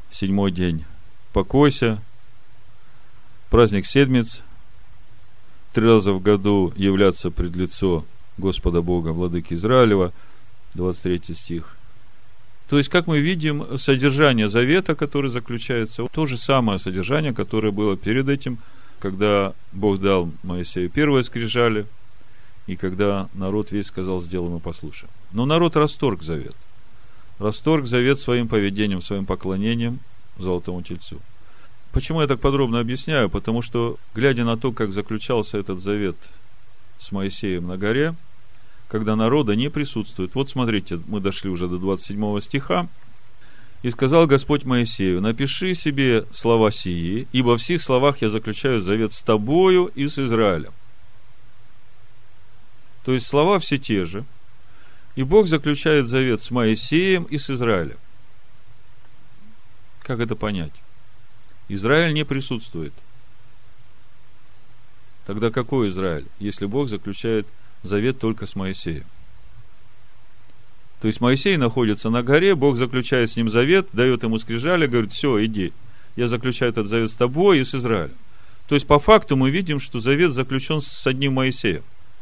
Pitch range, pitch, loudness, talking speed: 100-130 Hz, 115 Hz, -21 LUFS, 130 wpm